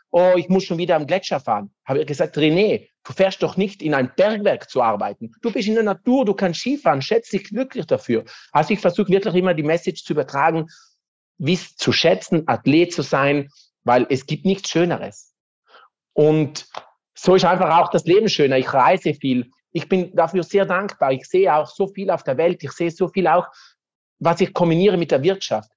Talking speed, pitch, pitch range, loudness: 205 wpm, 175 Hz, 150-195 Hz, -19 LUFS